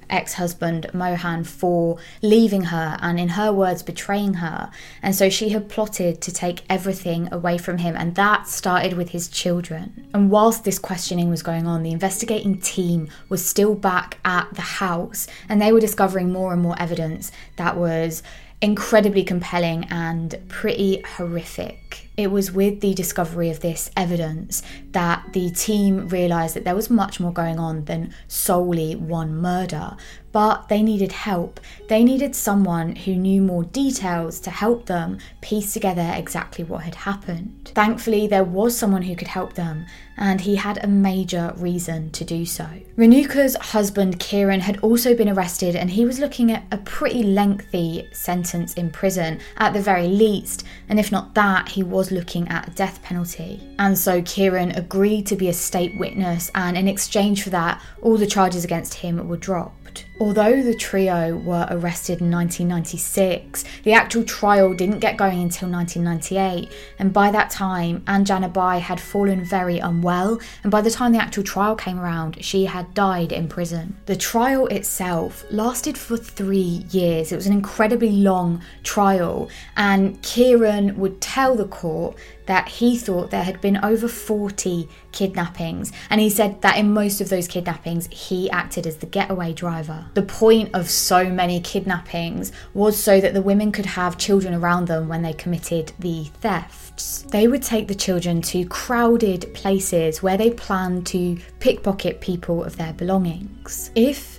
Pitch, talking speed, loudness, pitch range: 190 Hz, 170 wpm, -21 LUFS, 175-205 Hz